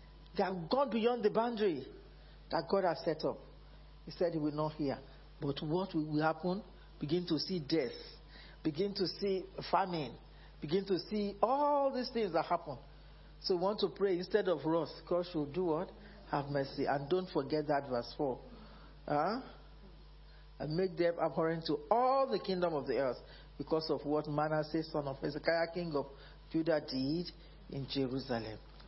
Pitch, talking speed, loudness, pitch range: 165 Hz, 170 wpm, -36 LUFS, 150-190 Hz